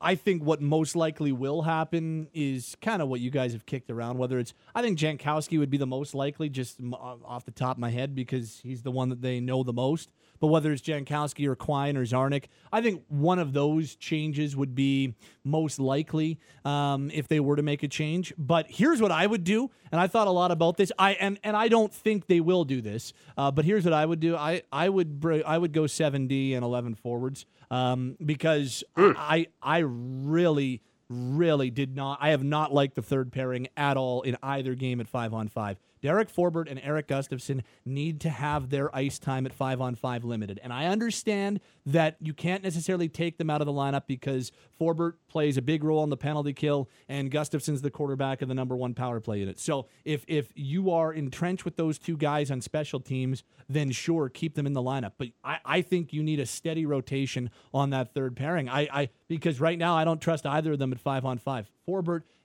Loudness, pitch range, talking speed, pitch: -28 LUFS, 130-160 Hz, 225 wpm, 145 Hz